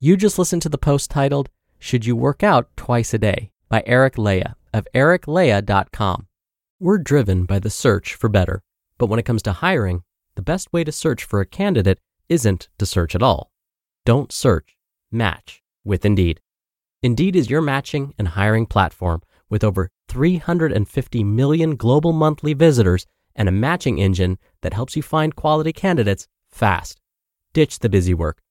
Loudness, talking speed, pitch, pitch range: -19 LUFS, 165 wpm, 115 Hz, 95-150 Hz